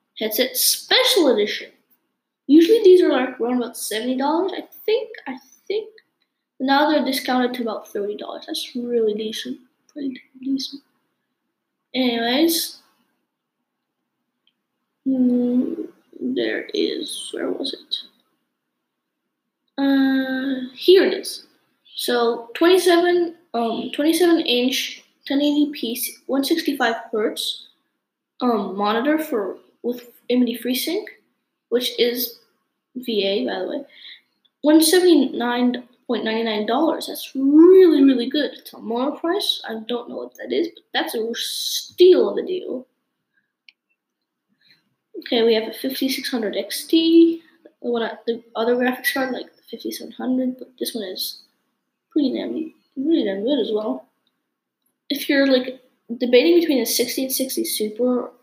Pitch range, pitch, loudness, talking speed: 245-325 Hz, 270 Hz, -20 LUFS, 125 wpm